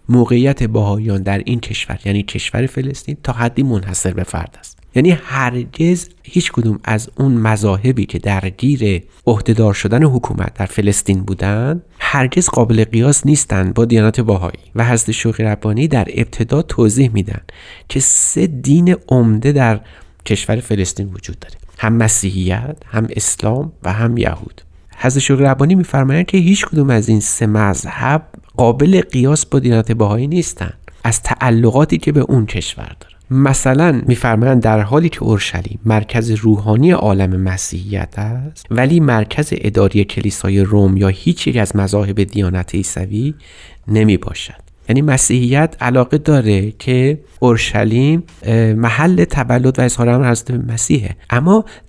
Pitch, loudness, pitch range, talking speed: 115 Hz, -14 LUFS, 100-135 Hz, 140 wpm